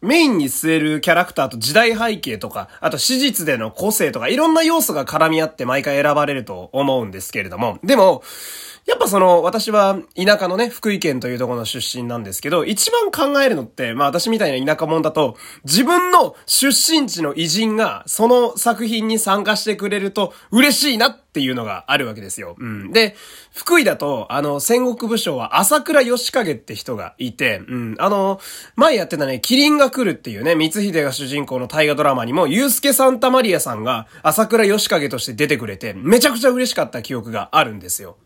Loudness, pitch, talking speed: -17 LUFS, 205 Hz, 395 characters per minute